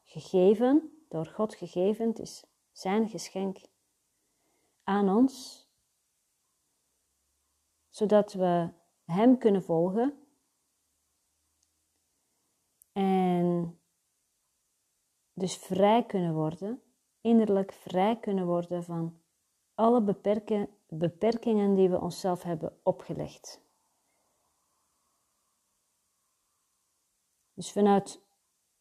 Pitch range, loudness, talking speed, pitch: 170-215 Hz, -28 LUFS, 75 wpm, 190 Hz